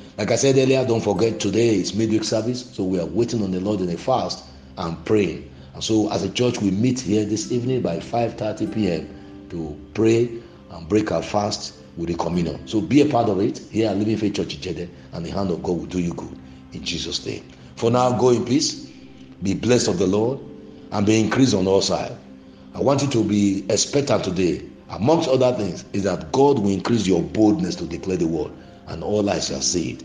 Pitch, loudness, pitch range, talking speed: 105 Hz, -21 LUFS, 85-115 Hz, 225 wpm